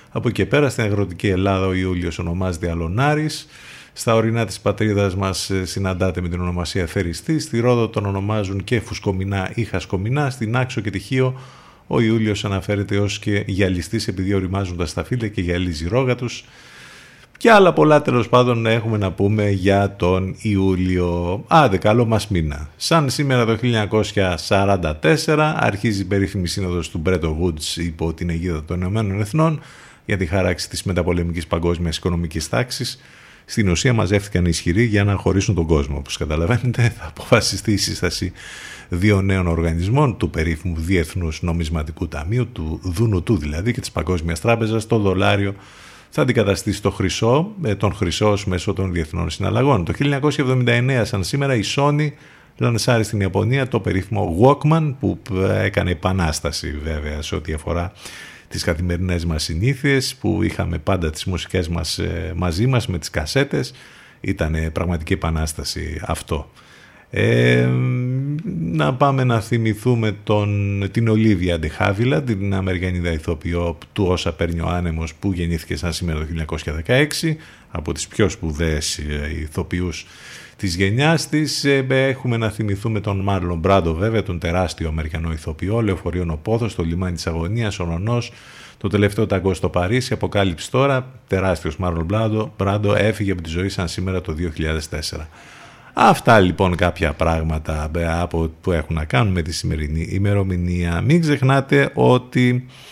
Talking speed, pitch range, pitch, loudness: 150 wpm, 85-115 Hz, 95 Hz, -20 LUFS